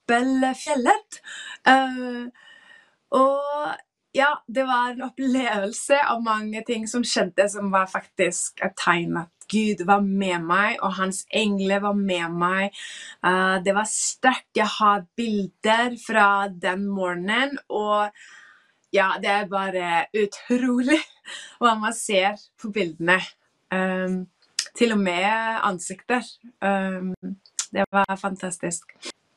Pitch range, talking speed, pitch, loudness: 190-245 Hz, 120 wpm, 205 Hz, -23 LUFS